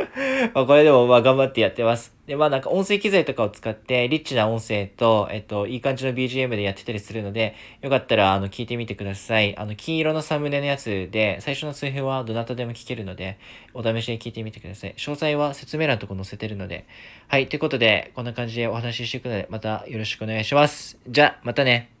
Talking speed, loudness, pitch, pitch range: 470 characters per minute, -22 LUFS, 120 Hz, 110-135 Hz